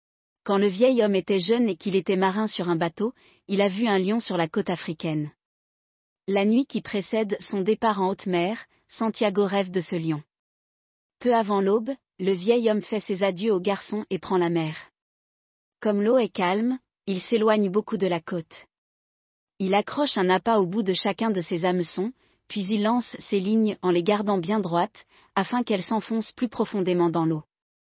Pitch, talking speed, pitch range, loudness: 200 Hz, 190 wpm, 185-220 Hz, -25 LUFS